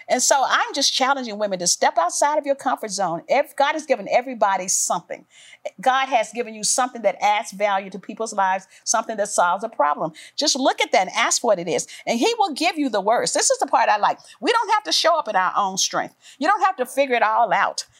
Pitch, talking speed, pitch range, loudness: 260 Hz, 250 wpm, 210-310 Hz, -20 LUFS